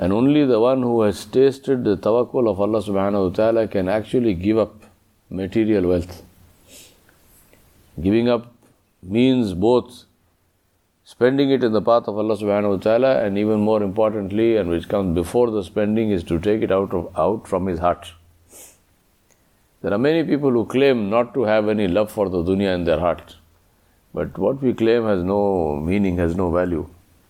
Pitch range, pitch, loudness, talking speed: 90-115 Hz, 100 Hz, -20 LUFS, 180 wpm